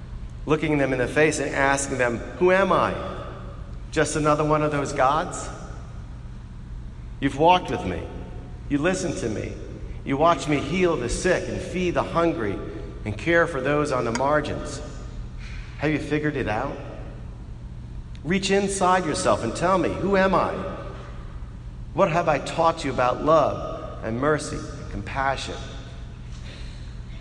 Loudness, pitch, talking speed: -23 LUFS, 135 Hz, 150 wpm